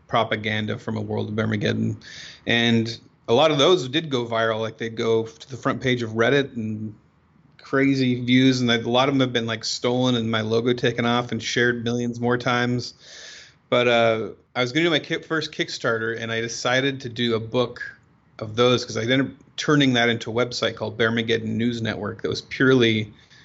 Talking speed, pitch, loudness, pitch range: 205 wpm, 120 Hz, -22 LUFS, 115-125 Hz